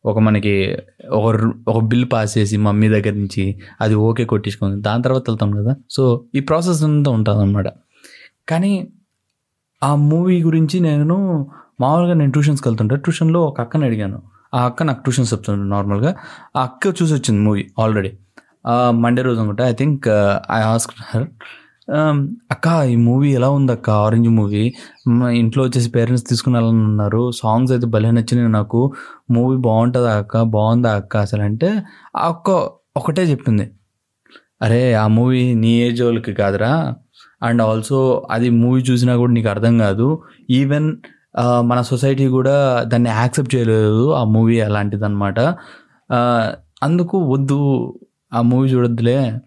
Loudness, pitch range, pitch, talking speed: -16 LUFS, 110-135 Hz, 120 Hz, 140 wpm